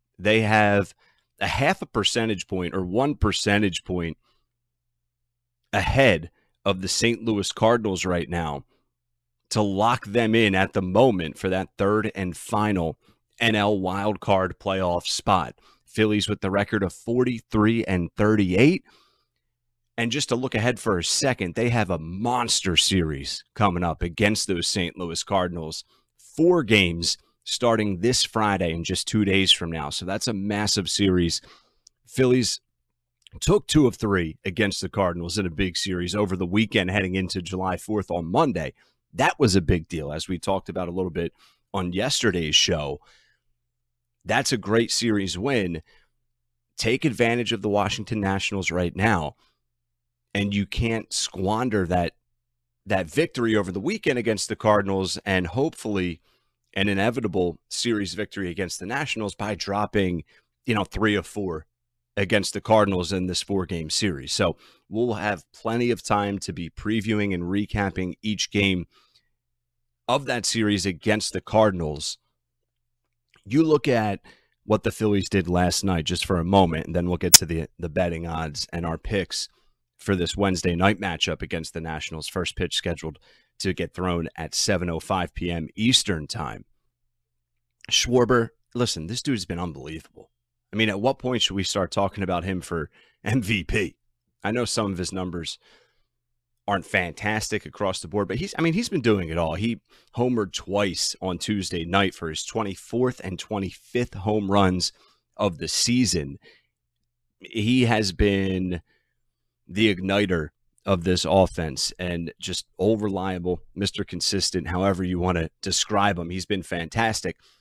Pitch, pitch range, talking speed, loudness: 100 Hz, 90-115 Hz, 155 wpm, -24 LUFS